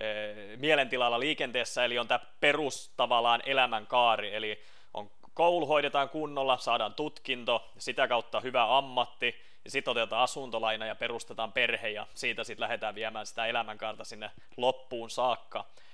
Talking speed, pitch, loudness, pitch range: 135 wpm, 120 Hz, -30 LUFS, 110-135 Hz